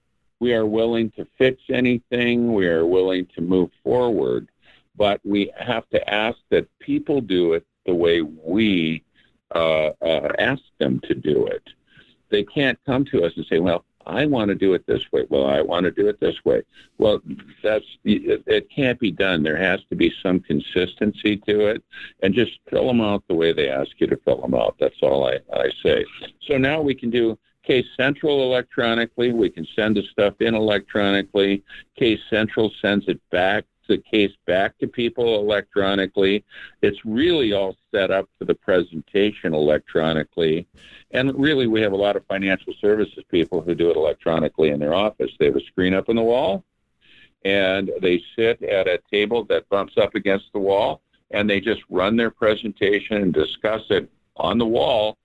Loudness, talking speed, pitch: -21 LUFS, 185 wpm, 115 Hz